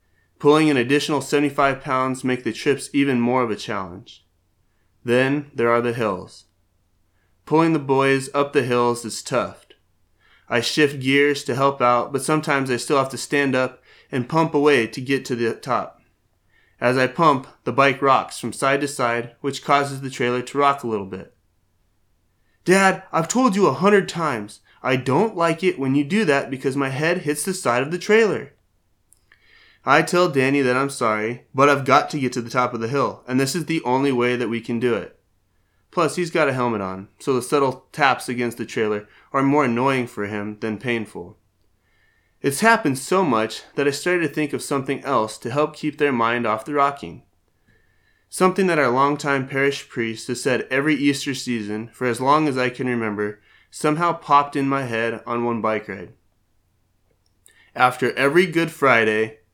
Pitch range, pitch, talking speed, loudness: 115-145 Hz, 130 Hz, 190 wpm, -20 LUFS